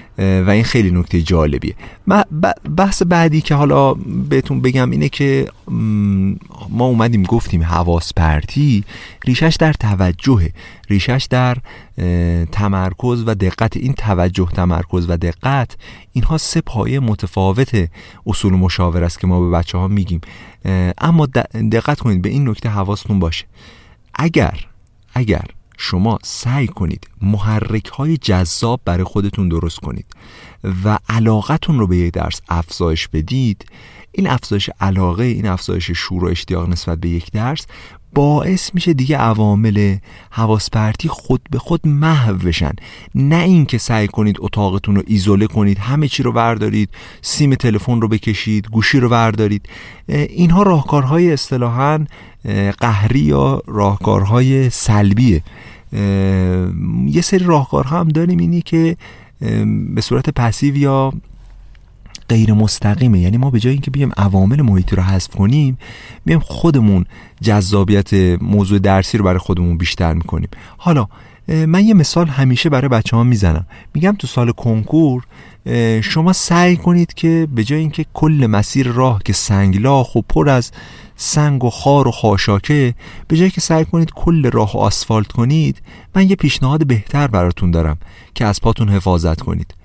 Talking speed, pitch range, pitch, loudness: 140 wpm, 95-135 Hz, 110 Hz, -15 LUFS